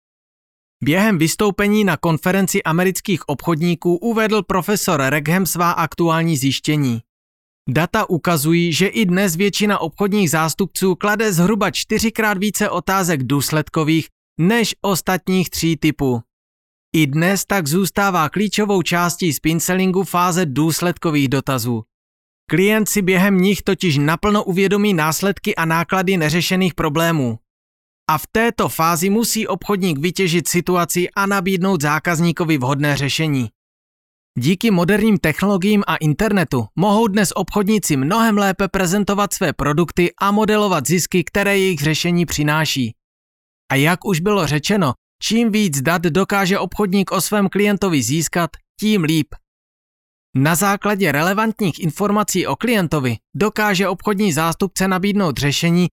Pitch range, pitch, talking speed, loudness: 155-200 Hz, 180 Hz, 120 wpm, -17 LUFS